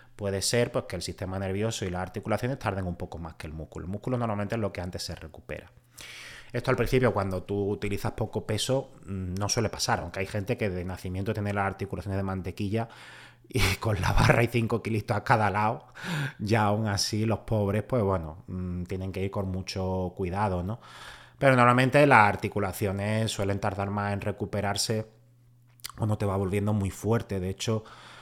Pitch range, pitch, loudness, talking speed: 95-115 Hz, 105 Hz, -28 LUFS, 190 wpm